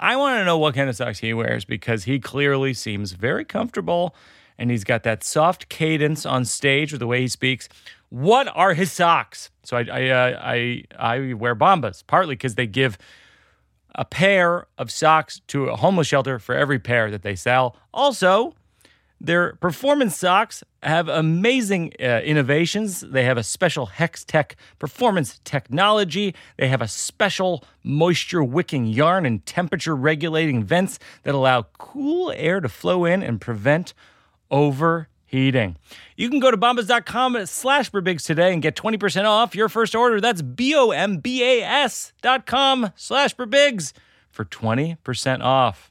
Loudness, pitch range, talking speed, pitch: -20 LUFS, 125-195 Hz, 150 wpm, 155 Hz